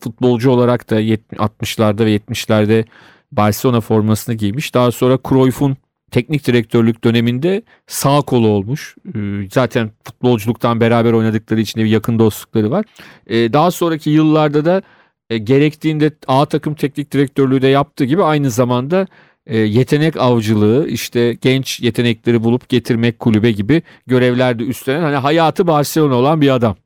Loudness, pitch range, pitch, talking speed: -15 LUFS, 115-145 Hz, 125 Hz, 130 wpm